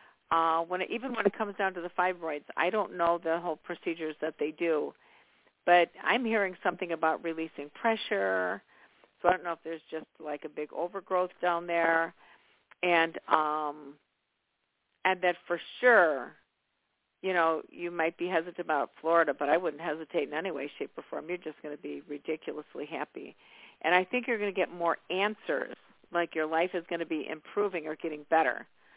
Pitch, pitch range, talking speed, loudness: 170 Hz, 160-180 Hz, 190 wpm, -31 LUFS